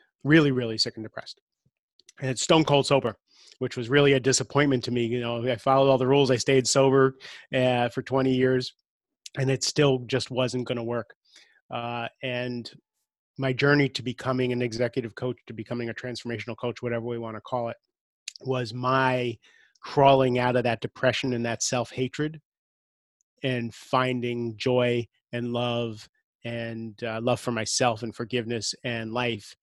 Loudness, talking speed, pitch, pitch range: -26 LUFS, 170 wpm, 125 Hz, 120-130 Hz